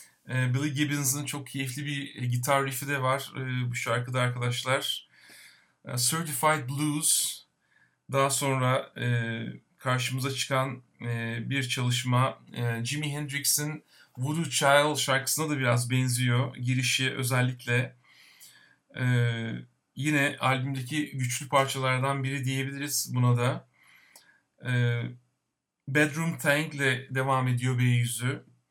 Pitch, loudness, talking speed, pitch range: 130 Hz, -28 LUFS, 90 wpm, 125-140 Hz